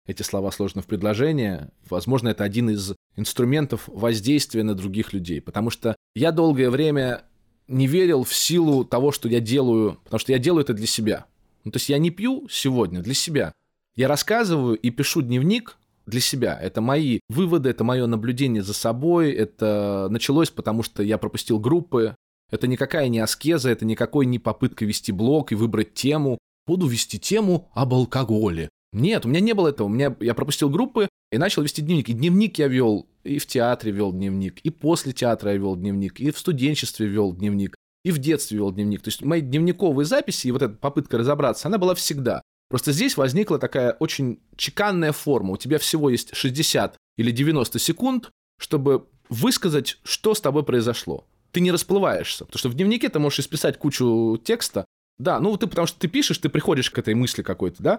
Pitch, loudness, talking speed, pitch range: 130 Hz, -22 LUFS, 190 wpm, 110-155 Hz